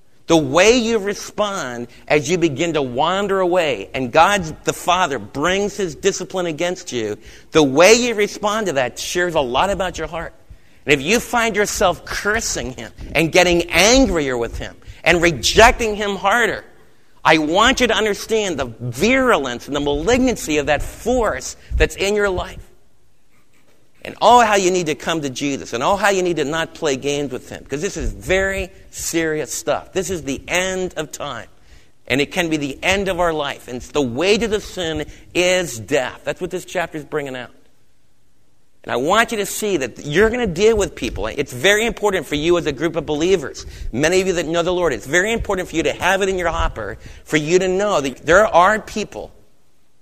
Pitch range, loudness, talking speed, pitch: 150-200 Hz, -18 LUFS, 205 wpm, 175 Hz